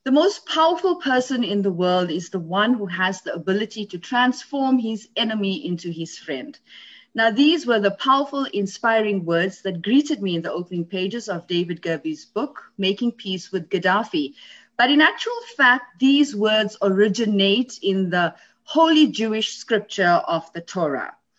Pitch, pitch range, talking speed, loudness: 210 Hz, 185-260 Hz, 165 wpm, -21 LUFS